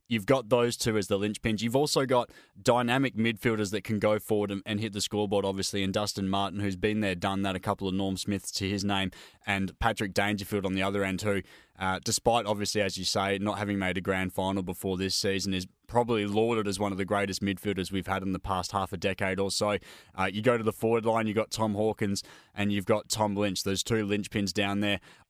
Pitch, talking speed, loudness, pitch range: 100 Hz, 240 wpm, -29 LUFS, 95-110 Hz